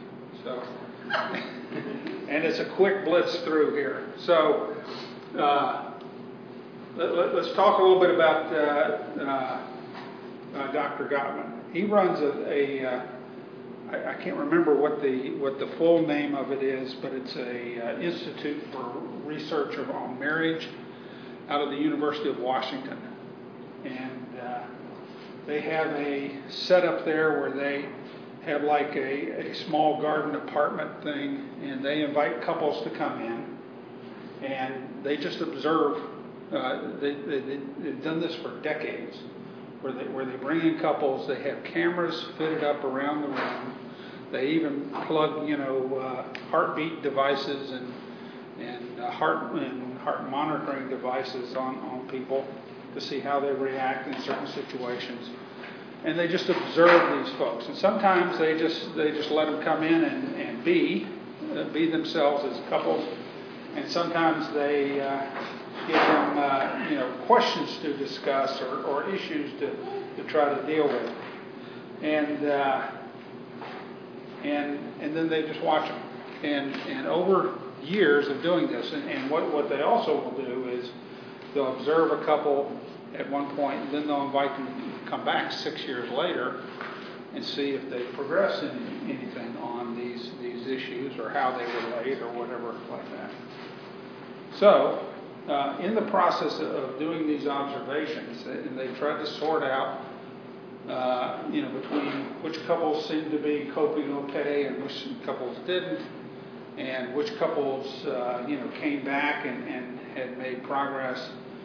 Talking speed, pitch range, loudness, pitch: 155 wpm, 130-155 Hz, -28 LUFS, 145 Hz